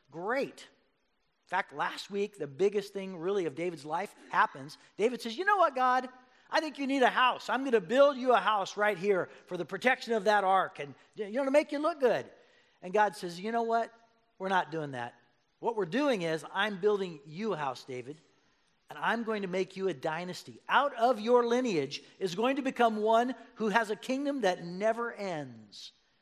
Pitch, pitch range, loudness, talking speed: 215 Hz, 180-245 Hz, -31 LUFS, 210 wpm